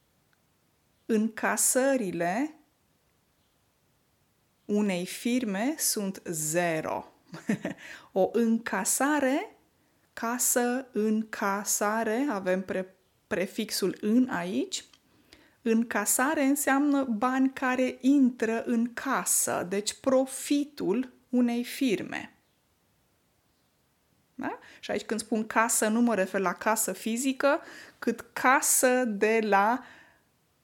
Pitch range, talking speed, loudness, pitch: 210-255 Hz, 80 wpm, -27 LUFS, 230 Hz